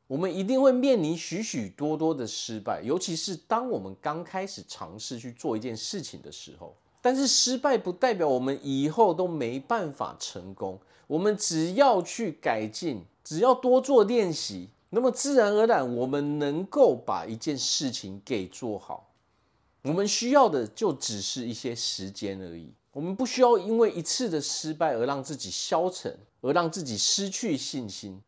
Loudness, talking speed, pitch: -27 LUFS, 260 characters per minute, 155 Hz